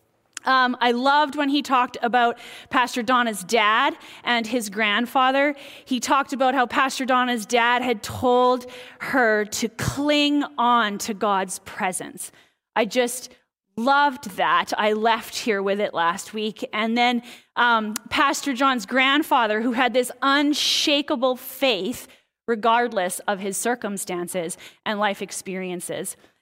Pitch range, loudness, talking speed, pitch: 215-265 Hz, -22 LUFS, 130 wpm, 245 Hz